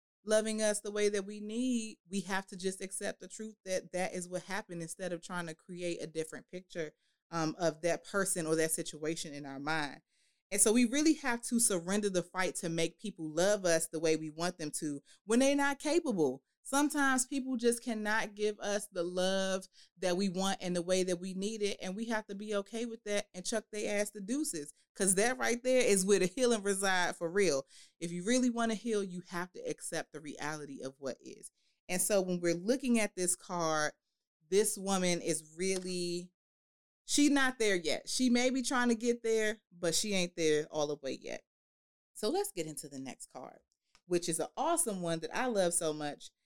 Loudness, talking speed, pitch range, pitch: -34 LUFS, 215 wpm, 170-220 Hz, 190 Hz